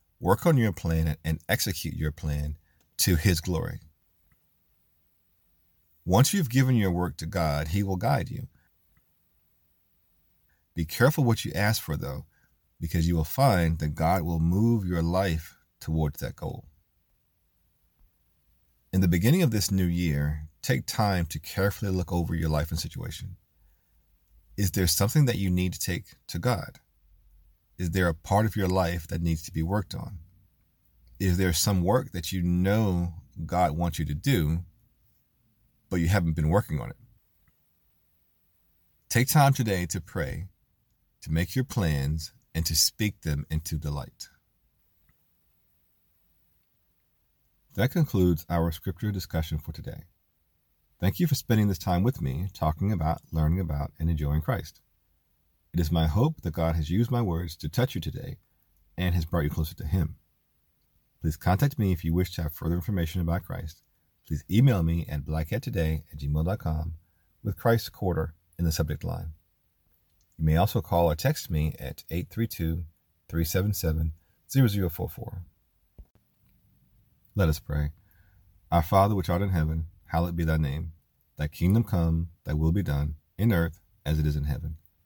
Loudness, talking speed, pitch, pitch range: -27 LUFS, 155 wpm, 85 Hz, 80-95 Hz